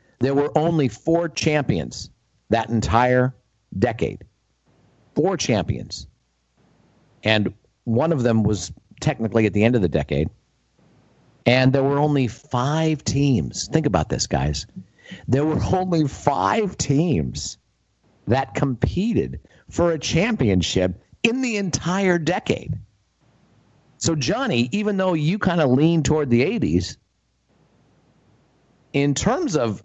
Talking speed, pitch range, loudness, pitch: 120 wpm, 110-160 Hz, -21 LUFS, 135 Hz